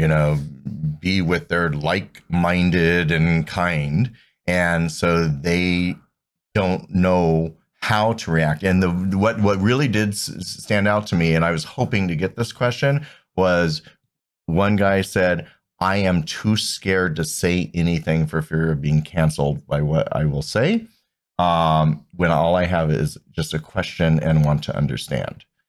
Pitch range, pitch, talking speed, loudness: 80-95 Hz, 85 Hz, 160 wpm, -20 LUFS